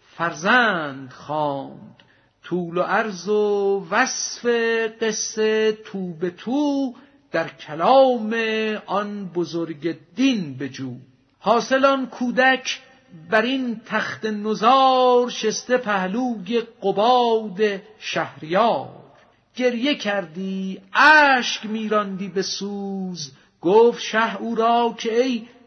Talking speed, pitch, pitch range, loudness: 95 wpm, 220 Hz, 190-245 Hz, -21 LUFS